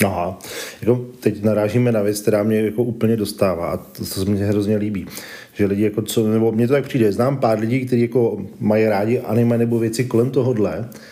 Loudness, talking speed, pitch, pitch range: -19 LUFS, 205 wpm, 110 Hz, 105-120 Hz